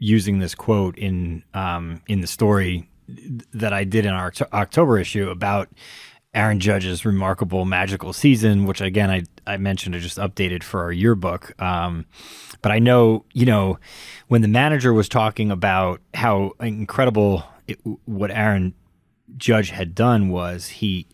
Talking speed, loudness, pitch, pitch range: 155 wpm, -20 LUFS, 100 Hz, 90-110 Hz